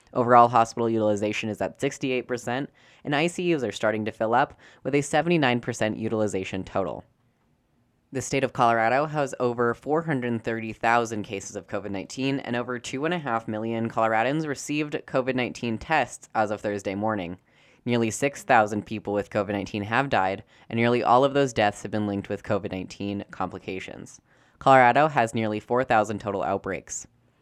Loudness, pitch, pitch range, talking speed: -25 LUFS, 115 Hz, 105-130 Hz, 150 wpm